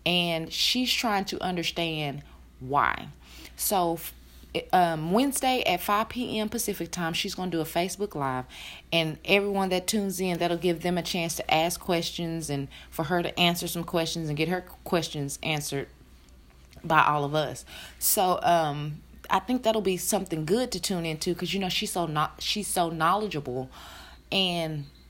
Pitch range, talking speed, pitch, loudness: 155-190 Hz, 165 wpm, 170 Hz, -27 LUFS